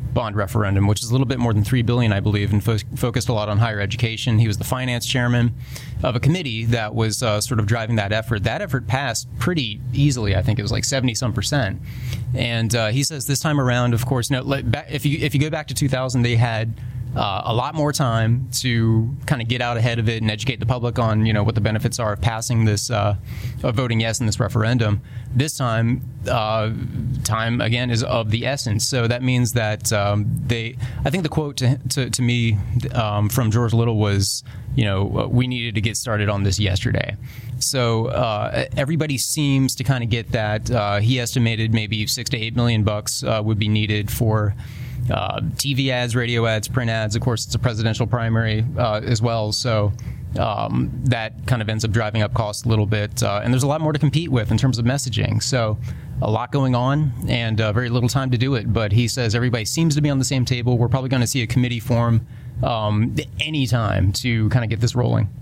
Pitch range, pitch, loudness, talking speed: 110-125 Hz, 120 Hz, -21 LUFS, 230 wpm